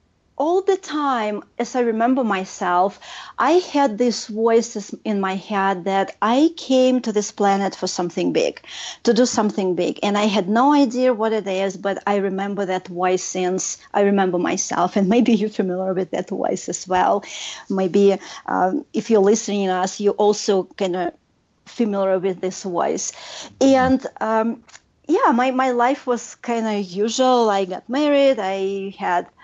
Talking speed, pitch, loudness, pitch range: 170 wpm, 210 Hz, -20 LUFS, 195-245 Hz